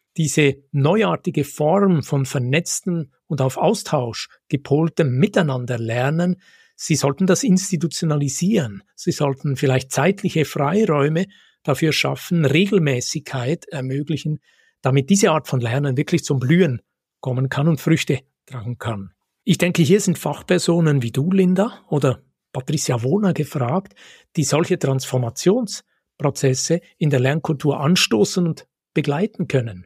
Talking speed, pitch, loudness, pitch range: 120 wpm, 155 Hz, -20 LUFS, 135-180 Hz